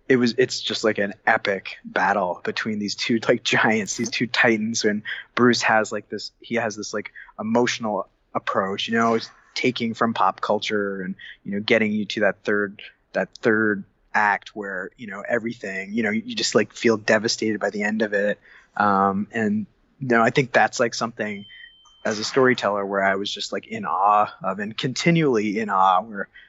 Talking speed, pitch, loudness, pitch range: 195 wpm, 110 Hz, -22 LUFS, 105-120 Hz